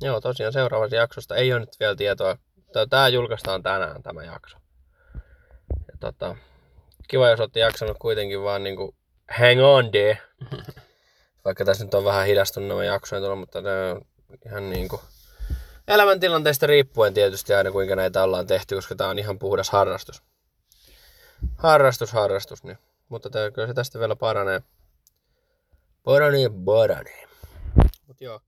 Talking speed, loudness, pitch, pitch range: 145 wpm, -21 LUFS, 105 Hz, 95-130 Hz